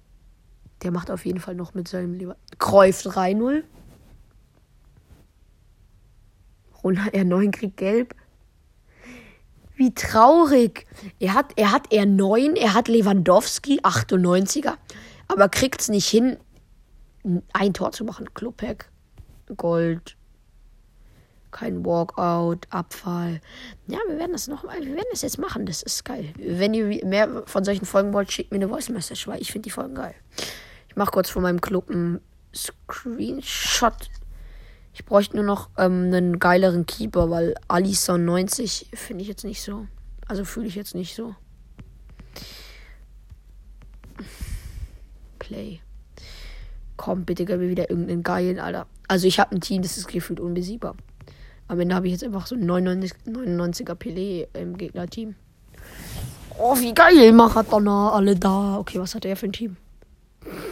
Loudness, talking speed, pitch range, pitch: -22 LUFS, 145 wpm, 175-215 Hz, 190 Hz